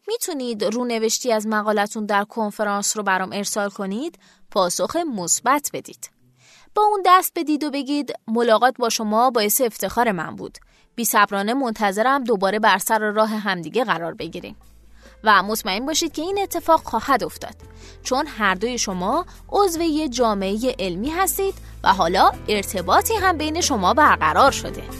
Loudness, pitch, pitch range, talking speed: -20 LUFS, 230 Hz, 205-305 Hz, 145 wpm